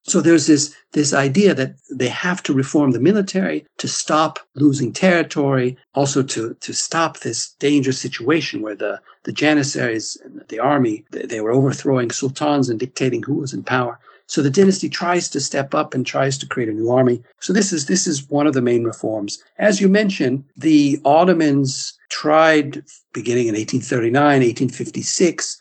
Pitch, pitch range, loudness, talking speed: 140 Hz, 130-160 Hz, -18 LUFS, 175 wpm